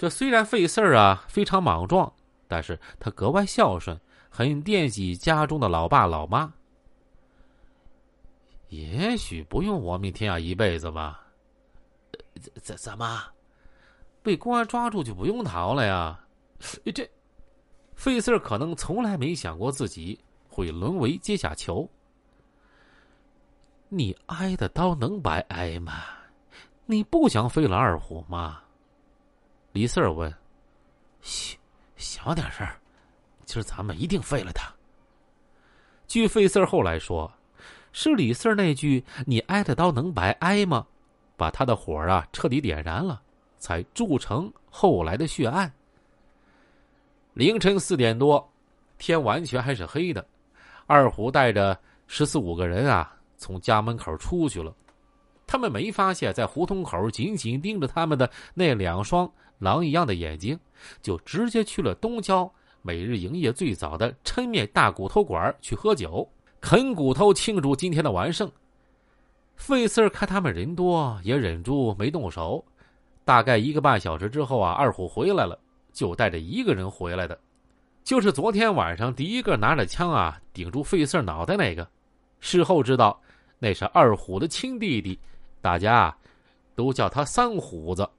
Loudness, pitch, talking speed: -25 LUFS, 140 Hz, 215 characters per minute